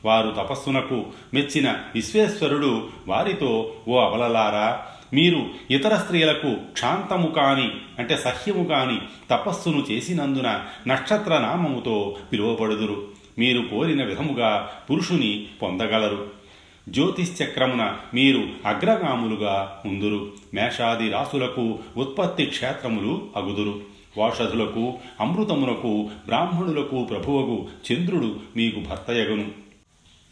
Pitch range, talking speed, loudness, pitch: 105-140 Hz, 80 wpm, -23 LUFS, 120 Hz